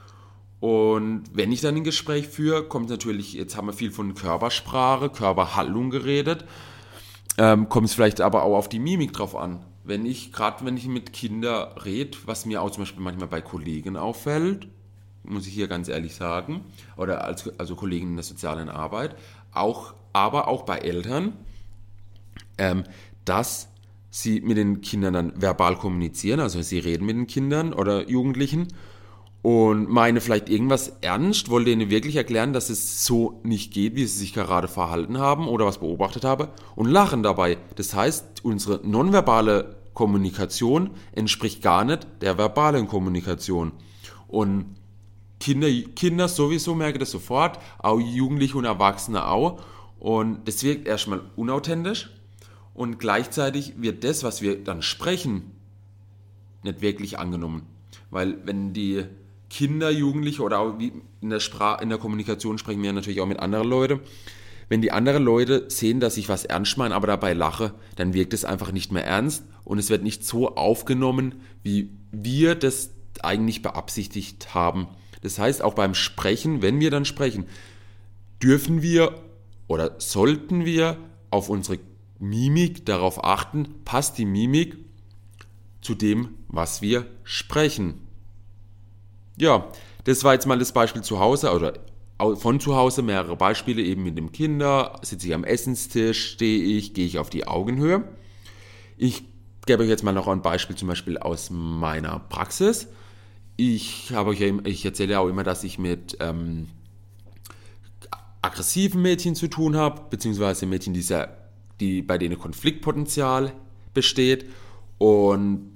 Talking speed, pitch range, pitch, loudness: 155 wpm, 100-125 Hz, 105 Hz, -24 LUFS